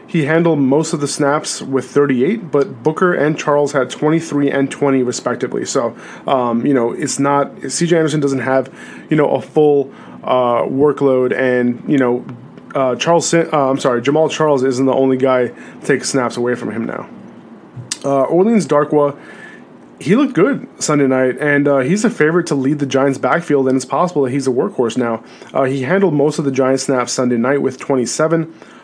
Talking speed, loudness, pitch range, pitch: 190 wpm, -15 LUFS, 130-150 Hz, 140 Hz